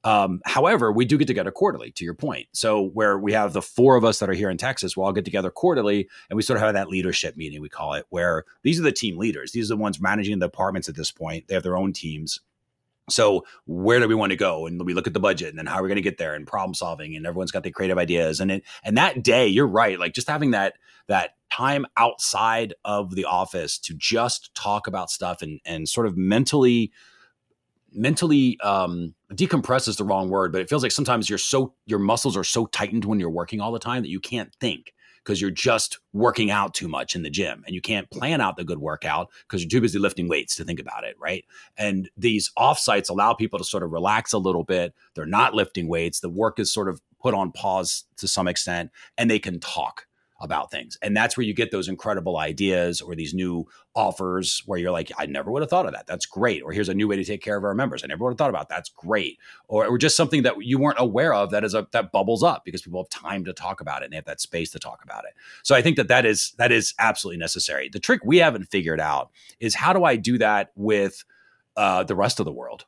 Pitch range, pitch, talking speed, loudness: 90-115 Hz, 100 Hz, 255 wpm, -23 LUFS